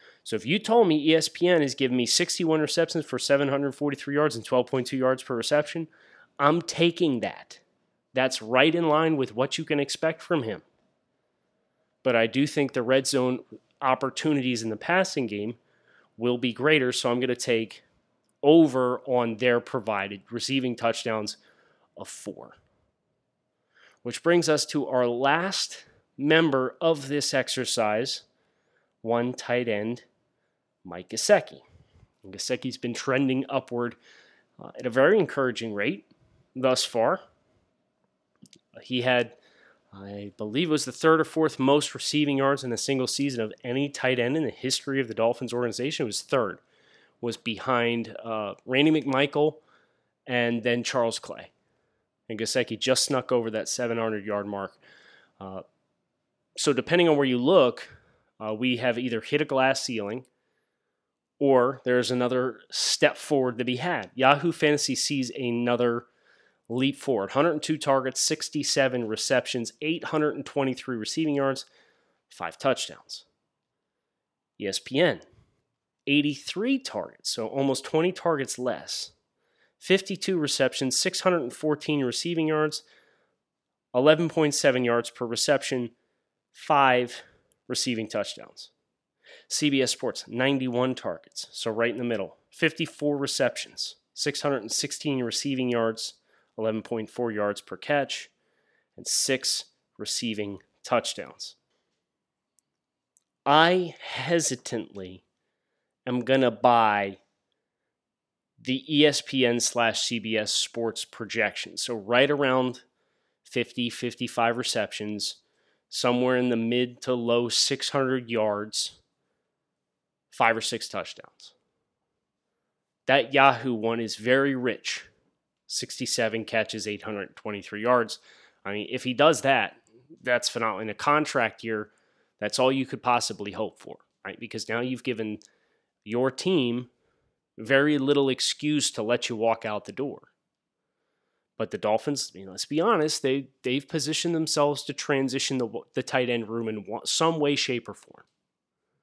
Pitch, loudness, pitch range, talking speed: 125 Hz, -26 LUFS, 115-145 Hz, 130 wpm